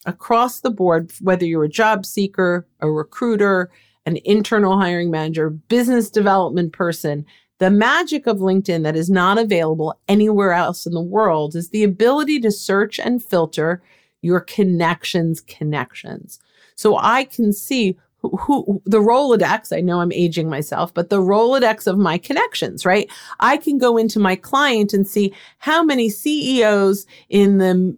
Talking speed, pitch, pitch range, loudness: 155 wpm, 195 Hz, 175-220 Hz, -17 LUFS